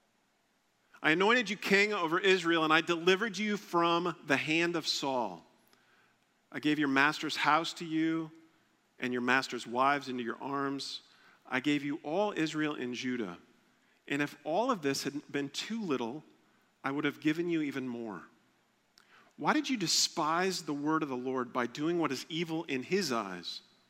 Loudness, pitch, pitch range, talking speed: -31 LUFS, 150 Hz, 135-170 Hz, 175 wpm